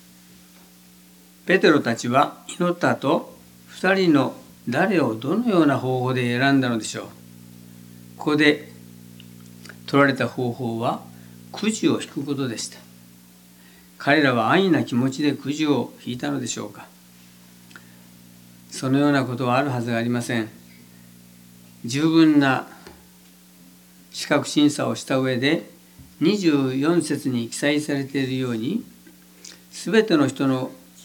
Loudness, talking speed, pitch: -22 LUFS, 230 characters per minute, 110 Hz